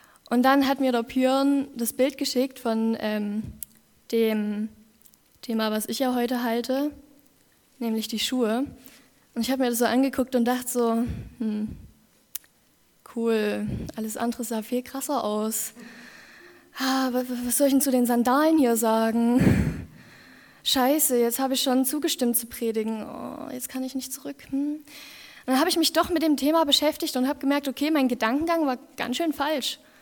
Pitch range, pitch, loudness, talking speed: 230-280 Hz, 255 Hz, -25 LUFS, 170 wpm